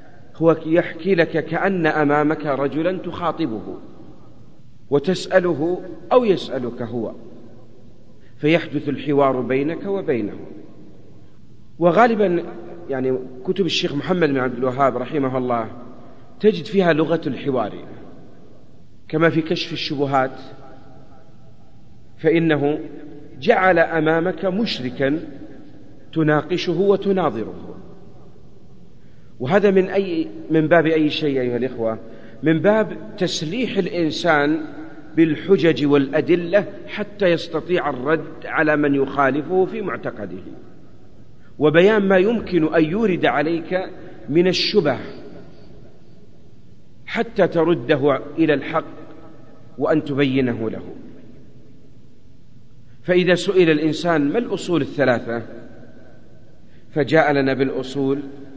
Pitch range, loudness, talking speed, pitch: 135-175 Hz, -19 LUFS, 90 wpm, 155 Hz